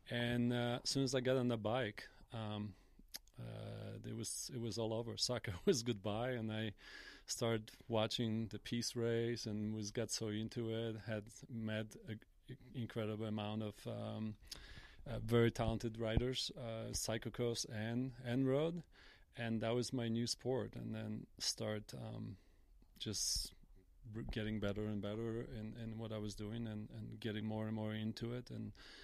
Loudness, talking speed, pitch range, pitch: -42 LUFS, 170 wpm, 110-120 Hz, 110 Hz